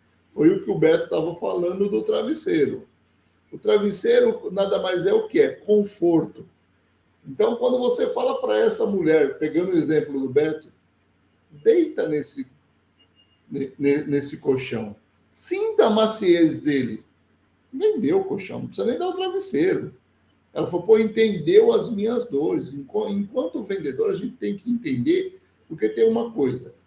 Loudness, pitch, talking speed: -22 LUFS, 210 Hz, 145 wpm